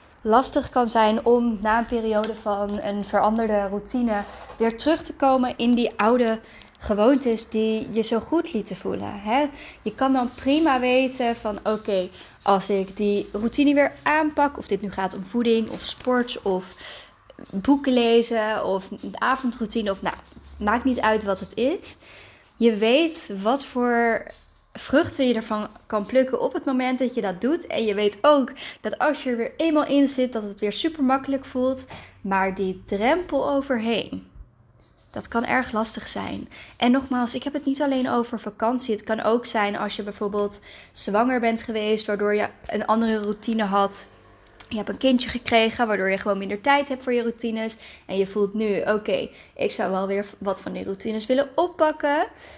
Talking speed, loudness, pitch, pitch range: 180 wpm, -23 LUFS, 230 Hz, 210-260 Hz